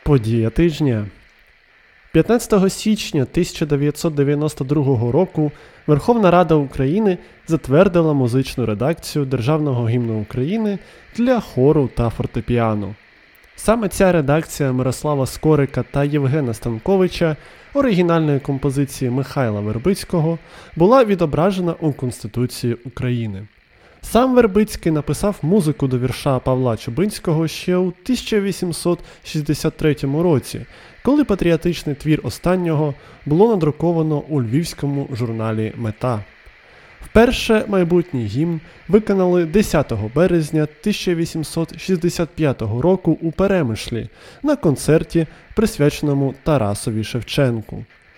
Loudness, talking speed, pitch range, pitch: -18 LUFS, 90 wpm, 130-175 Hz, 155 Hz